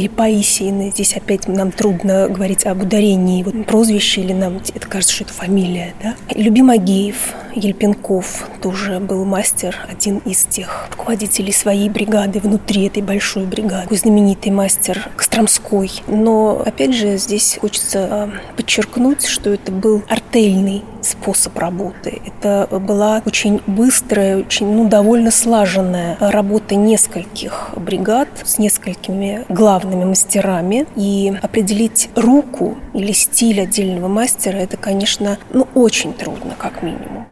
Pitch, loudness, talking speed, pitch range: 205 Hz, -14 LUFS, 125 wpm, 195-220 Hz